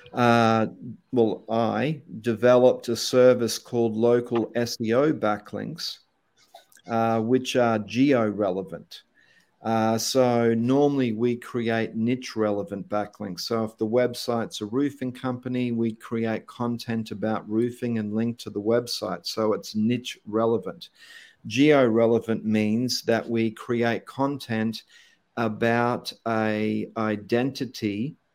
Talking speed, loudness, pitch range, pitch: 115 wpm, -25 LUFS, 110-120 Hz, 115 Hz